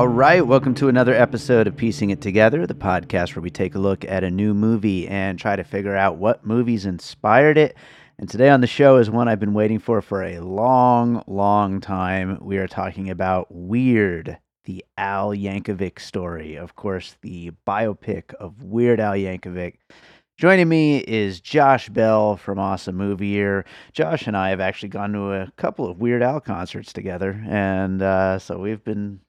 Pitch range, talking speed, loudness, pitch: 95-115 Hz, 185 wpm, -20 LUFS, 100 Hz